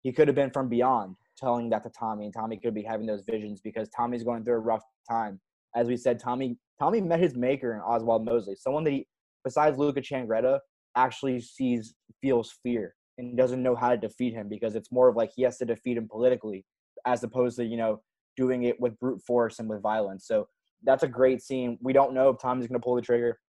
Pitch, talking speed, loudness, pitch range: 120 Hz, 230 wpm, -28 LUFS, 115-130 Hz